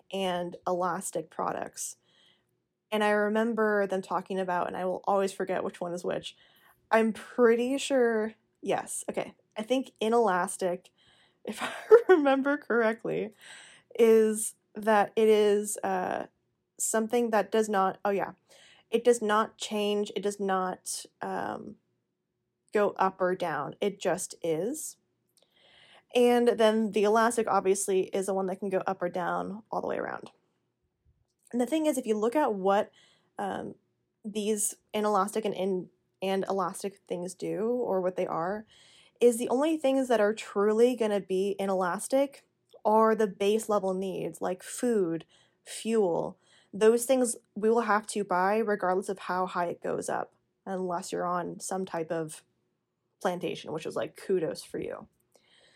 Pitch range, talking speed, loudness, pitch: 190-225 Hz, 150 wpm, -29 LUFS, 205 Hz